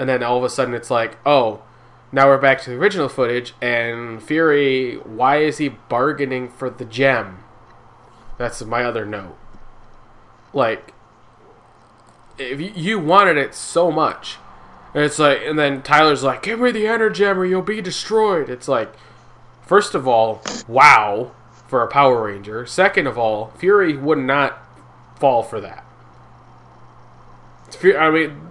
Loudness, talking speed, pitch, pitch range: -17 LUFS, 155 wpm, 135 Hz, 120-160 Hz